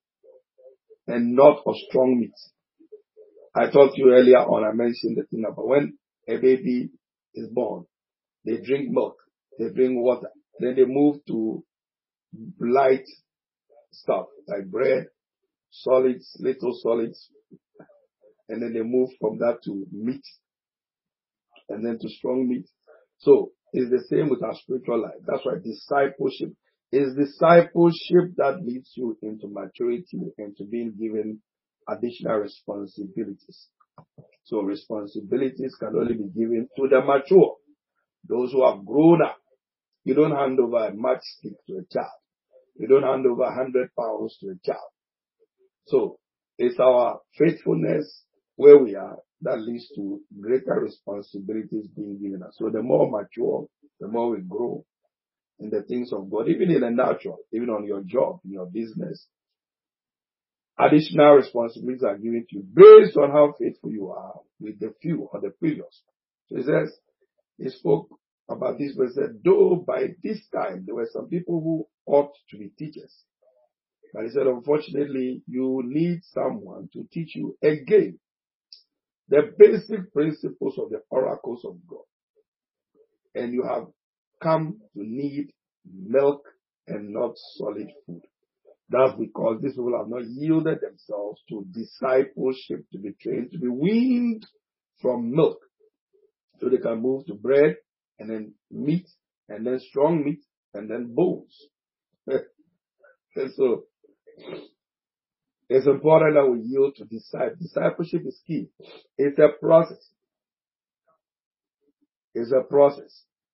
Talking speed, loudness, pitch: 140 wpm, -22 LUFS, 140 Hz